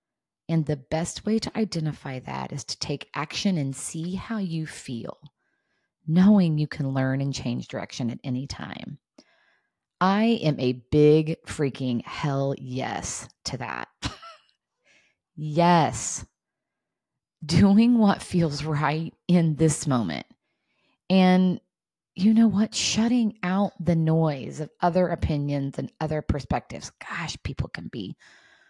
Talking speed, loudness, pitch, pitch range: 130 wpm, -25 LUFS, 160 Hz, 140-185 Hz